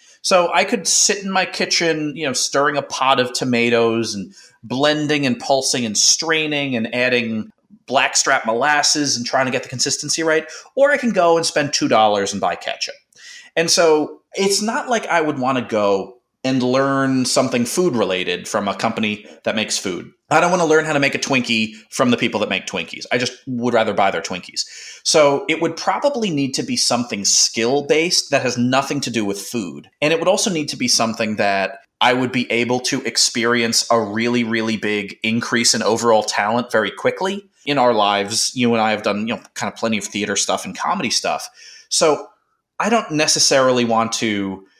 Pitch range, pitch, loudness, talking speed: 115-160 Hz, 130 Hz, -18 LUFS, 205 wpm